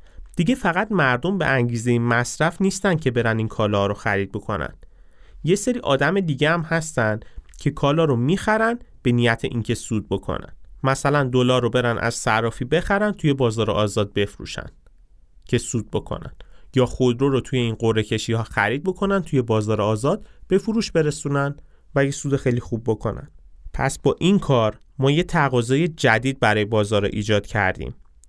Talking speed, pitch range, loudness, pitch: 165 wpm, 110-150 Hz, -21 LUFS, 125 Hz